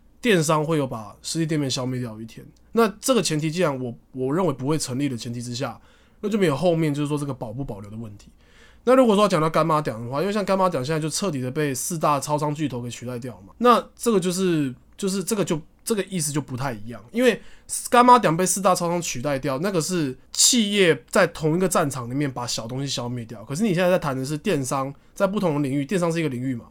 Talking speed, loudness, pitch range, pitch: 370 characters per minute, -22 LUFS, 130-185 Hz, 155 Hz